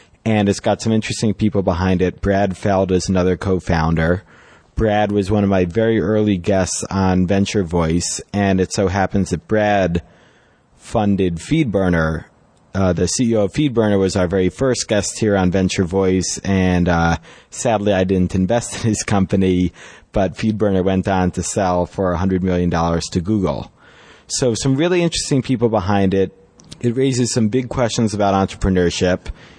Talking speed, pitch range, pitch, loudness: 165 wpm, 90-110 Hz, 95 Hz, -18 LUFS